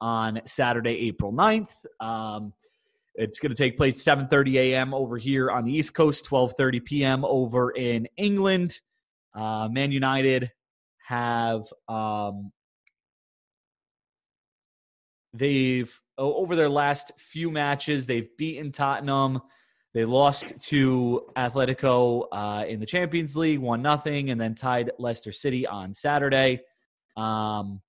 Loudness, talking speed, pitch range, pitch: -25 LUFS, 125 wpm, 115-145 Hz, 130 Hz